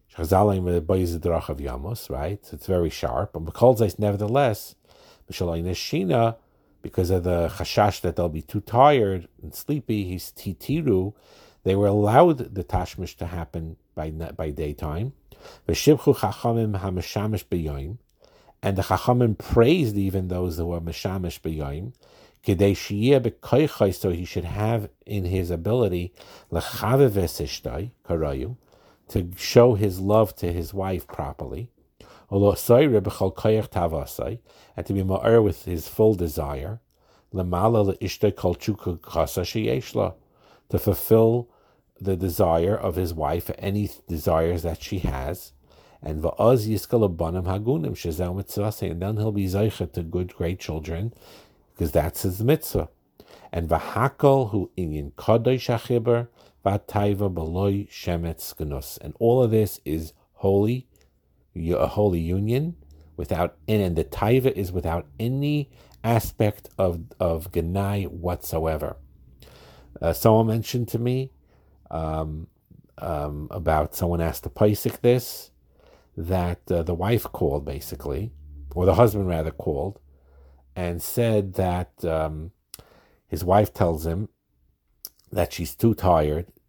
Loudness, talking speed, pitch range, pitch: -24 LUFS, 110 wpm, 85-110 Hz, 95 Hz